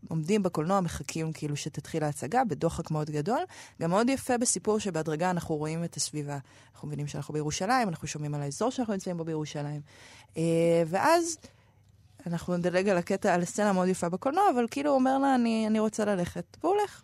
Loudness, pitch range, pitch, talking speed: -29 LUFS, 150-215 Hz, 175 Hz, 180 wpm